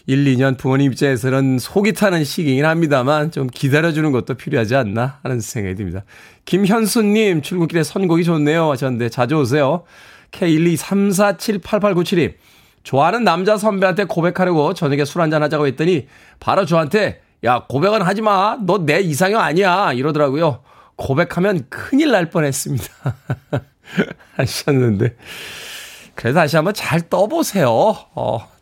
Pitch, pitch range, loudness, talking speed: 155 Hz, 135-190 Hz, -17 LUFS, 310 characters per minute